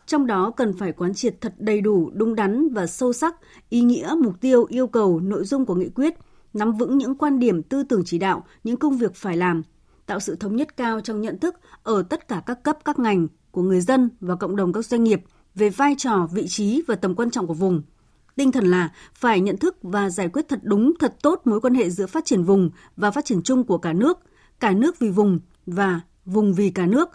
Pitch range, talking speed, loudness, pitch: 185-260 Hz, 245 wpm, -22 LUFS, 220 Hz